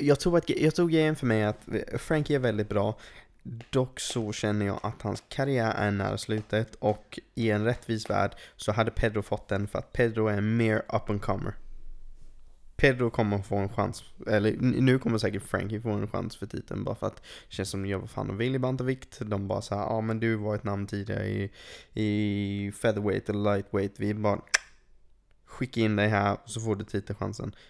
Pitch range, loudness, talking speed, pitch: 100-115 Hz, -29 LUFS, 210 wpm, 110 Hz